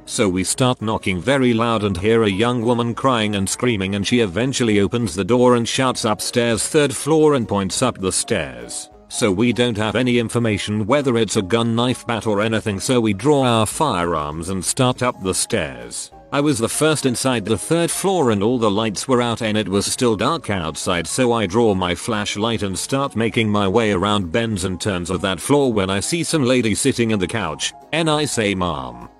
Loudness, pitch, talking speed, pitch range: -19 LUFS, 115 Hz, 215 wpm, 100-125 Hz